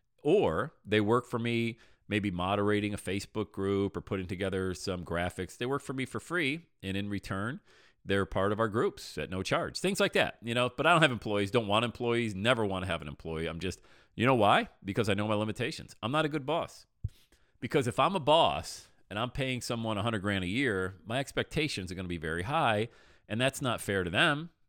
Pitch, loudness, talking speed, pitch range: 105 Hz, -31 LUFS, 225 wpm, 95-125 Hz